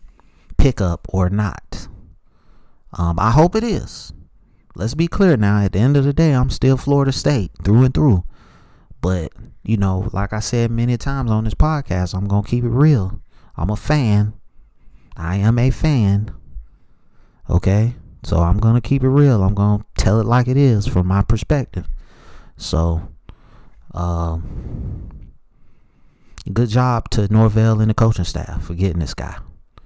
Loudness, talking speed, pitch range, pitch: -18 LUFS, 165 wpm, 90-125 Hz, 105 Hz